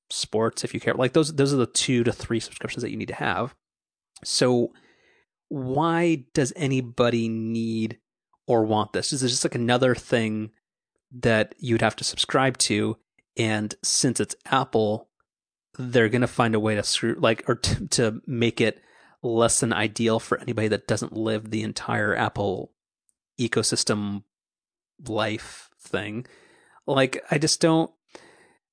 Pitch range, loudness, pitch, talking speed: 110-130 Hz, -24 LUFS, 115 Hz, 150 wpm